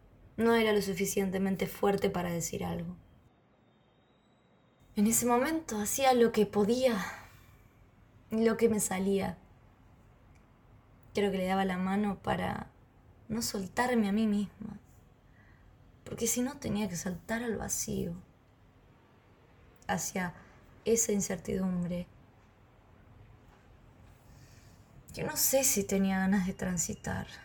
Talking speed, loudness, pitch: 110 wpm, -31 LUFS, 190 Hz